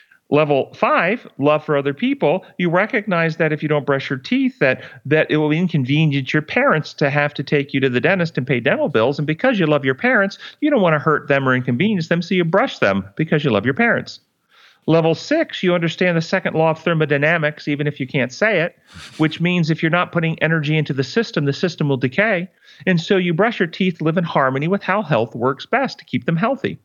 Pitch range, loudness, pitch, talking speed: 145-185 Hz, -18 LUFS, 160 Hz, 235 wpm